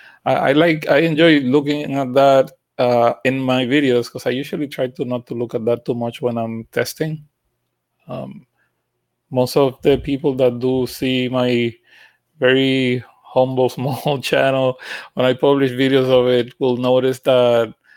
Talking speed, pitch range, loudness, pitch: 160 wpm, 125-140 Hz, -17 LUFS, 130 Hz